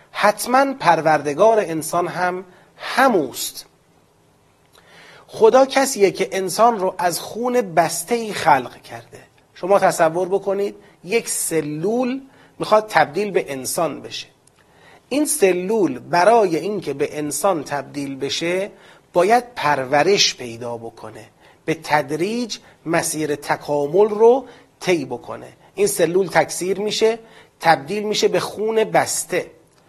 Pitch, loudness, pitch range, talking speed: 190 Hz, -19 LUFS, 160-220 Hz, 110 wpm